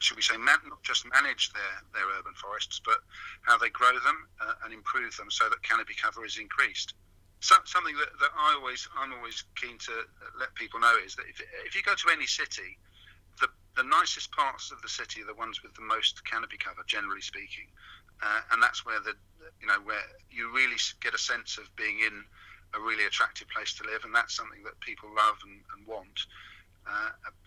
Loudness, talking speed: -29 LUFS, 210 wpm